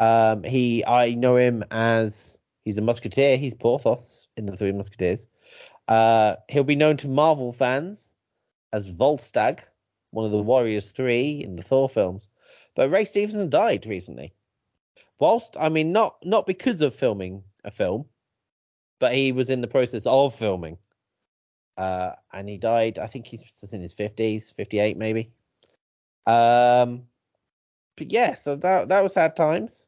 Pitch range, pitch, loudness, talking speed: 105-140 Hz, 120 Hz, -22 LUFS, 155 wpm